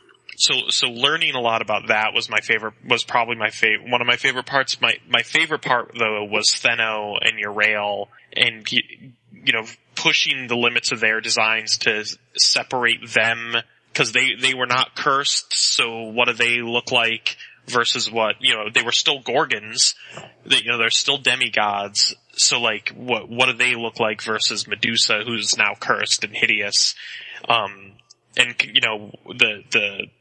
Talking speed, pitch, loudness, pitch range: 175 wpm, 115 Hz, -18 LUFS, 110-120 Hz